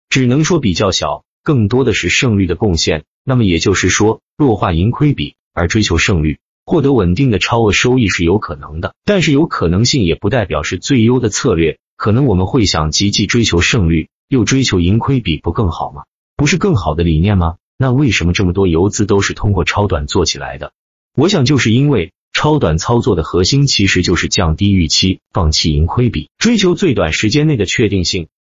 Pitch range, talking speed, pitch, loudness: 85-130 Hz, 310 characters per minute, 105 Hz, -13 LUFS